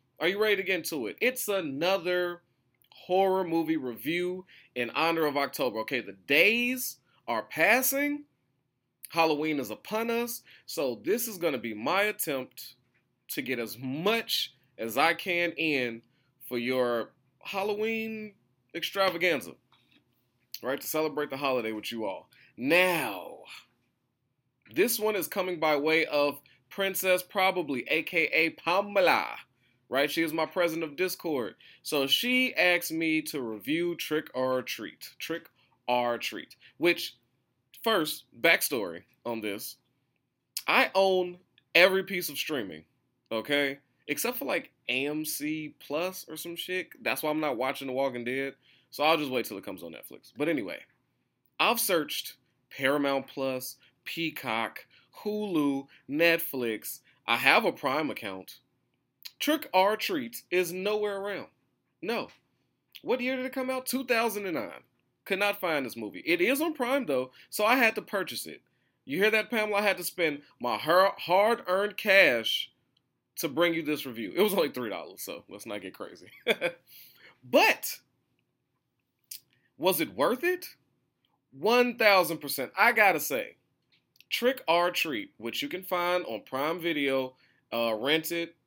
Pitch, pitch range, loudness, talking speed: 165 Hz, 130-195 Hz, -28 LUFS, 150 wpm